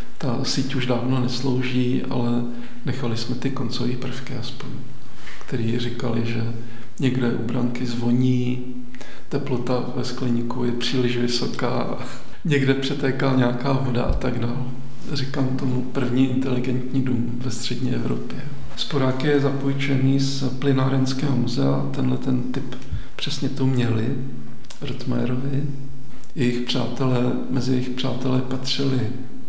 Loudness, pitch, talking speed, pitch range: -24 LUFS, 125 Hz, 120 wpm, 125-135 Hz